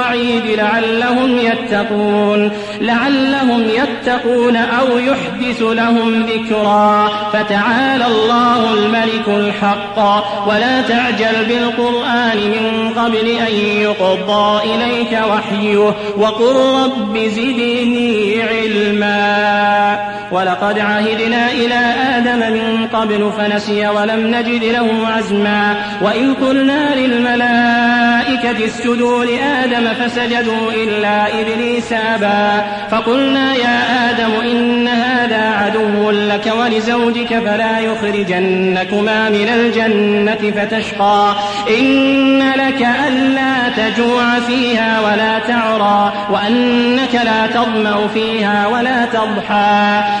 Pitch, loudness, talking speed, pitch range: 225 Hz, -13 LUFS, 85 wpm, 210-240 Hz